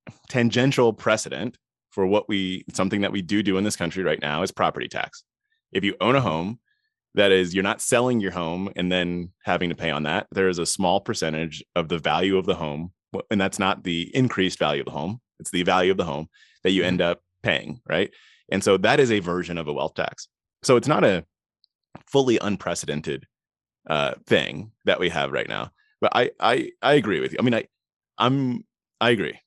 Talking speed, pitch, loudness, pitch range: 215 wpm, 95 Hz, -23 LUFS, 90-120 Hz